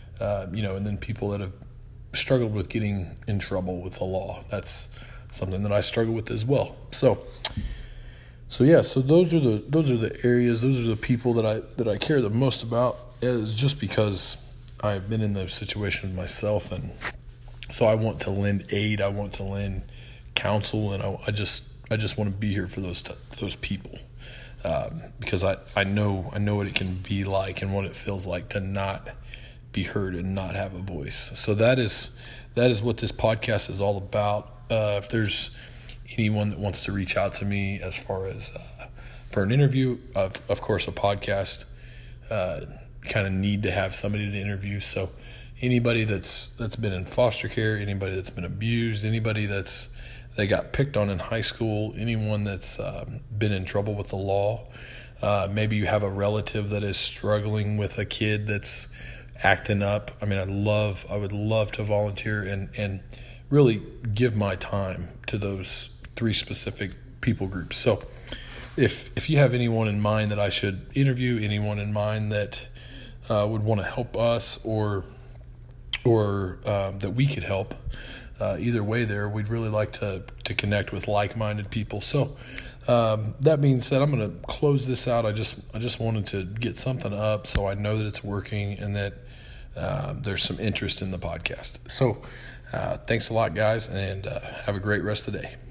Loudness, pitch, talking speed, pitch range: -26 LUFS, 105 Hz, 195 wpm, 100-120 Hz